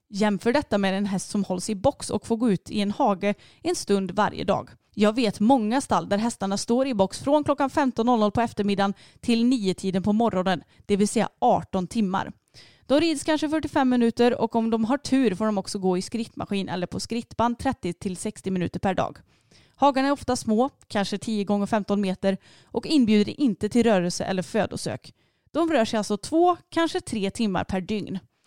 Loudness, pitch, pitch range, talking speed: -24 LUFS, 215 Hz, 200-250 Hz, 190 wpm